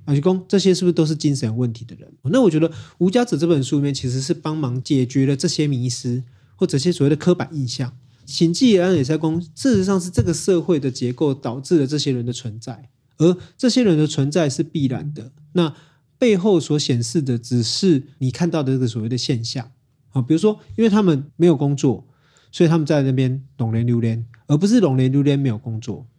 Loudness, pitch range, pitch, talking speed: -19 LUFS, 130-170 Hz, 145 Hz, 325 characters per minute